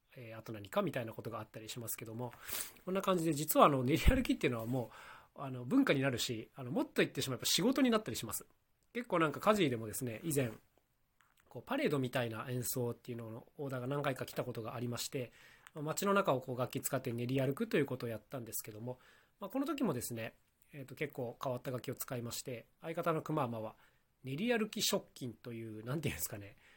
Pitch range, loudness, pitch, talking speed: 120-155 Hz, -37 LUFS, 130 Hz, 465 characters per minute